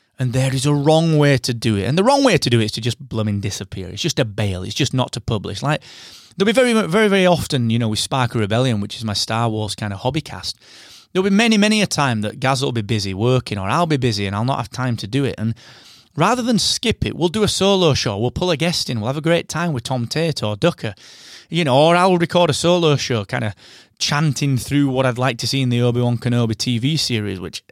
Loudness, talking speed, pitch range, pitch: -18 LUFS, 270 wpm, 115-165 Hz, 130 Hz